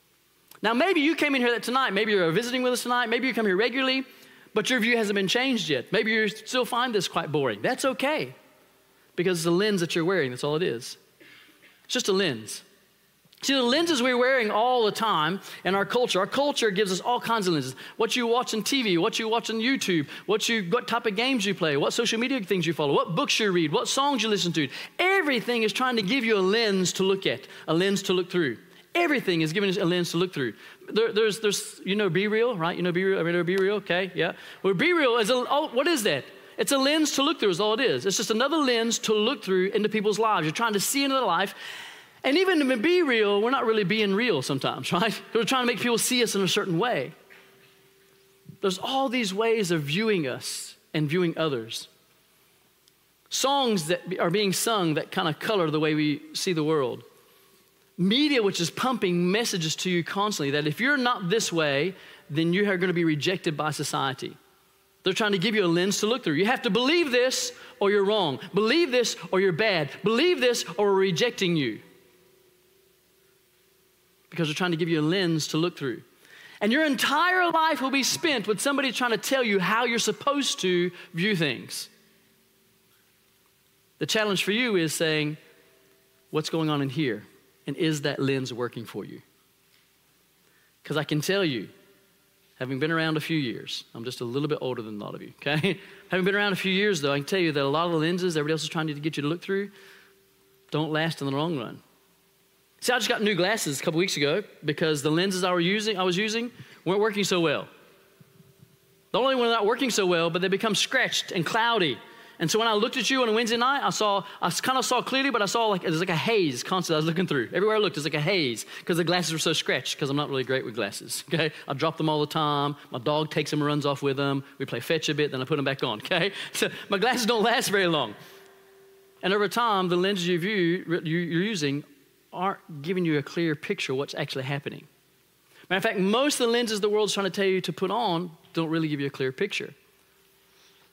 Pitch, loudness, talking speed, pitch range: 195 Hz, -25 LUFS, 235 wpm, 165-230 Hz